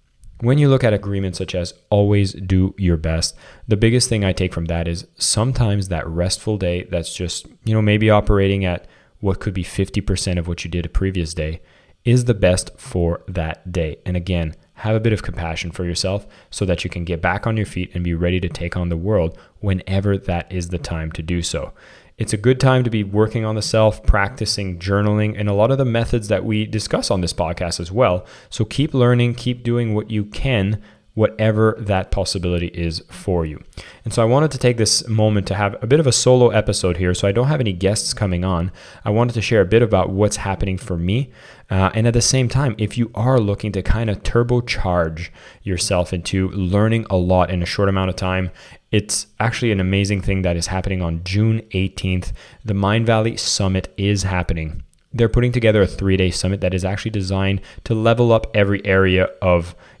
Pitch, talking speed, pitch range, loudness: 100 Hz, 215 wpm, 90-110 Hz, -19 LUFS